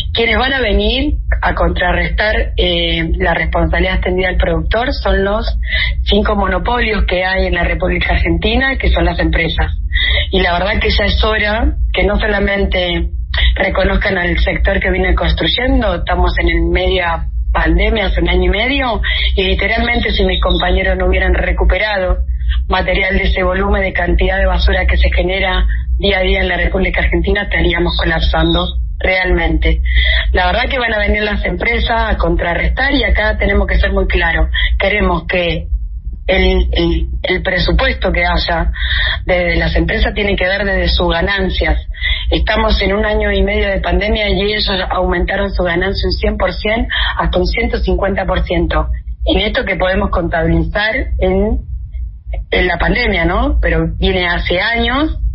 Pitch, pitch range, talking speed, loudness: 185 Hz, 160-200 Hz, 165 wpm, -14 LUFS